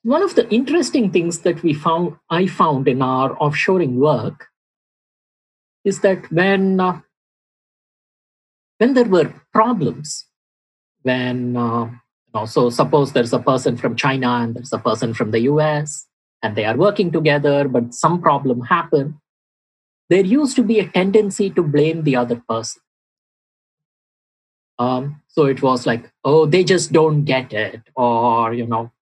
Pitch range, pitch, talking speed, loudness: 125-180 Hz, 150 Hz, 155 wpm, -17 LUFS